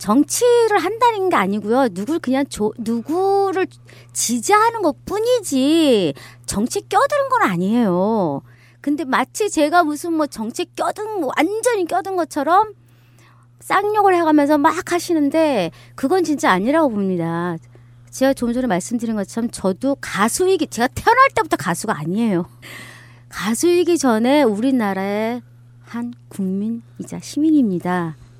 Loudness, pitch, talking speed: -18 LUFS, 245 Hz, 285 characters per minute